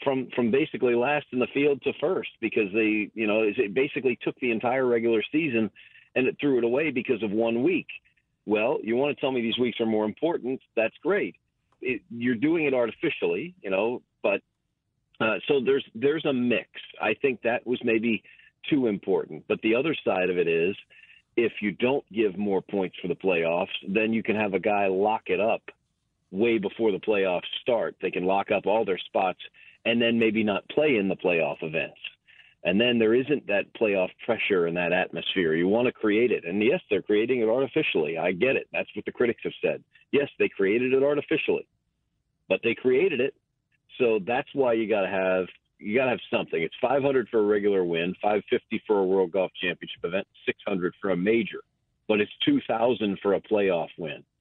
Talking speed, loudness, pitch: 200 wpm, -26 LUFS, 120 Hz